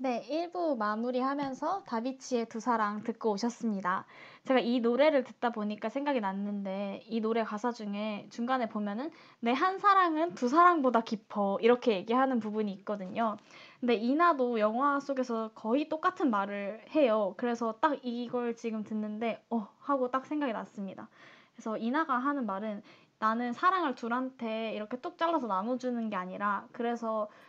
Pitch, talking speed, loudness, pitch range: 235 Hz, 340 characters per minute, -31 LUFS, 215-270 Hz